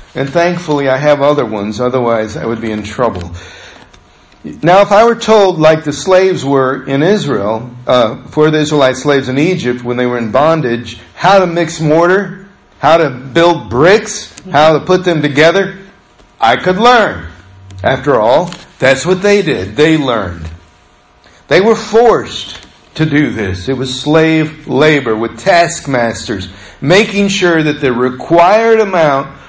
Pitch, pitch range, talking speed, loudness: 150 Hz, 120-180 Hz, 155 wpm, -11 LUFS